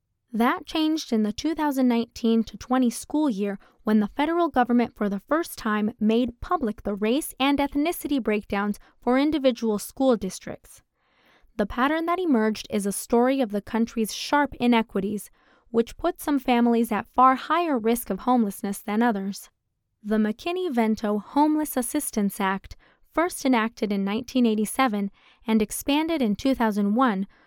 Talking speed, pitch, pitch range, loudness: 140 wpm, 235 Hz, 210-280 Hz, -24 LUFS